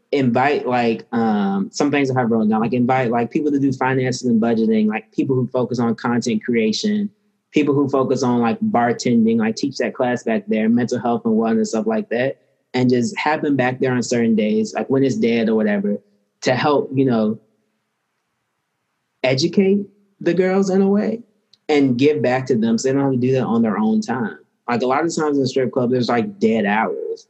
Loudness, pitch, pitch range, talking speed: -19 LUFS, 125 Hz, 115-155 Hz, 215 wpm